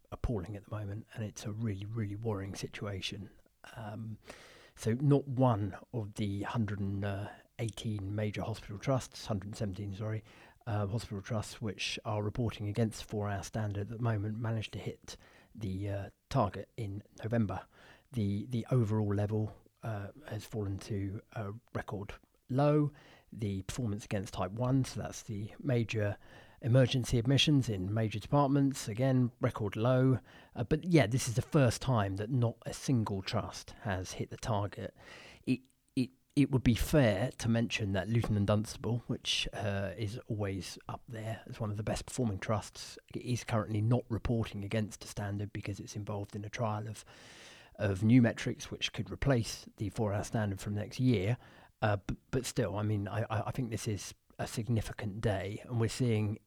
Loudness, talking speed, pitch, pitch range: -35 LUFS, 170 wpm, 110 Hz, 105-120 Hz